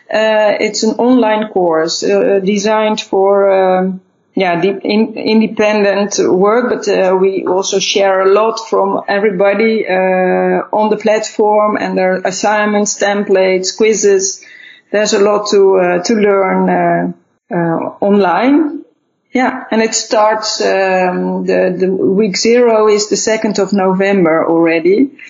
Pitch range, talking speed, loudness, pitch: 185-215 Hz, 135 wpm, -12 LUFS, 200 Hz